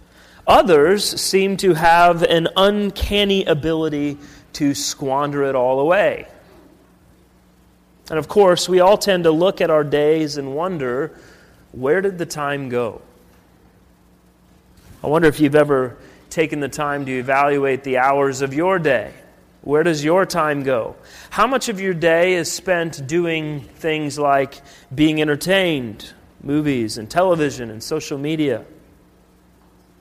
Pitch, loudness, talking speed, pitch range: 150 Hz, -18 LUFS, 135 wpm, 140-170 Hz